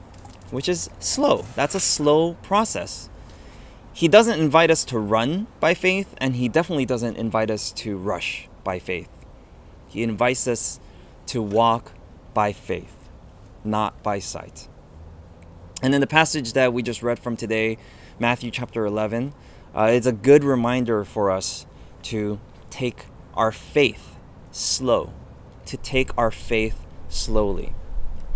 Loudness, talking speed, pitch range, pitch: -22 LUFS, 140 wpm, 95-130 Hz, 115 Hz